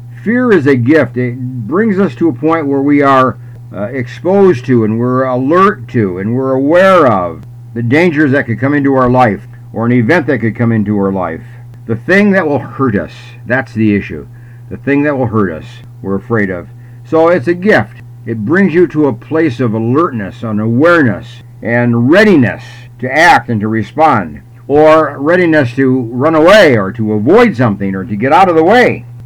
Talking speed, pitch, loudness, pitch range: 195 wpm, 120 Hz, -10 LUFS, 115-145 Hz